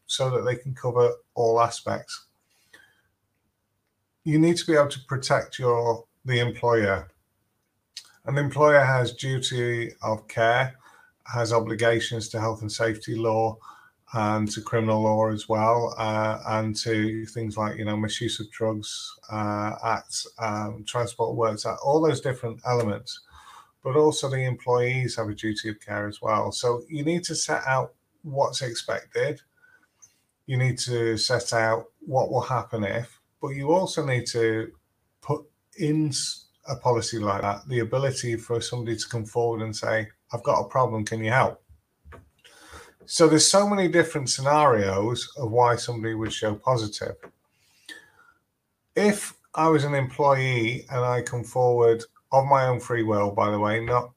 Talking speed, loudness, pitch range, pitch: 155 wpm, -25 LUFS, 110-130 Hz, 115 Hz